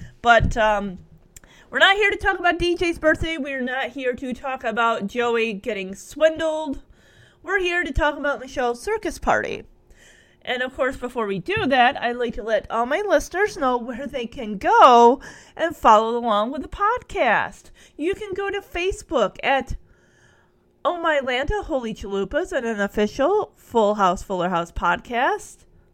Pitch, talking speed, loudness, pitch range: 265 Hz, 165 wpm, -21 LUFS, 230-325 Hz